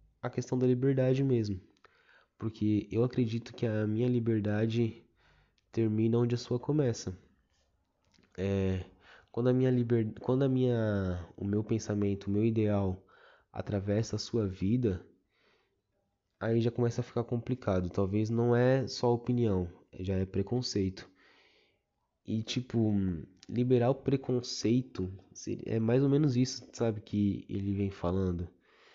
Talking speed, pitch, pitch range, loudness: 135 wpm, 110 Hz, 100-120 Hz, -32 LUFS